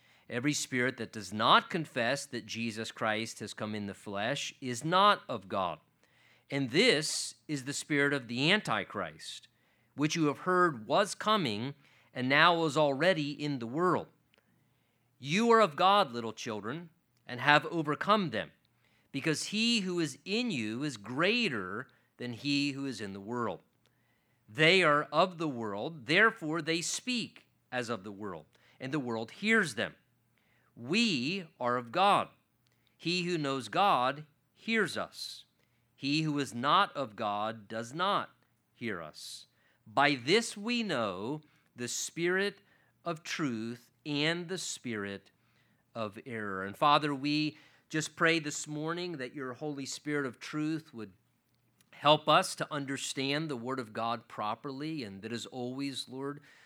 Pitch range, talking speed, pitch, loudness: 115-160 Hz, 150 wpm, 140 Hz, -31 LUFS